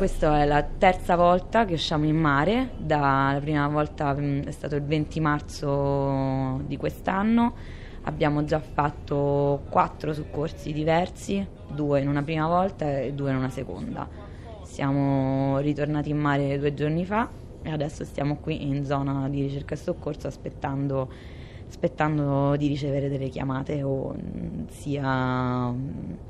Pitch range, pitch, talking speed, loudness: 135-155 Hz, 145 Hz, 135 wpm, -26 LUFS